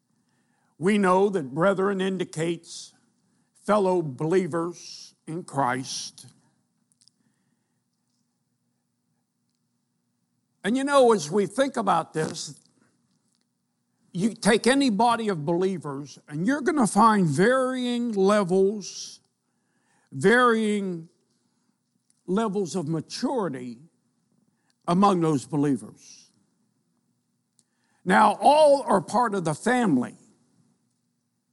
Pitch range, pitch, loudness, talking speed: 170-225 Hz, 195 Hz, -23 LUFS, 85 wpm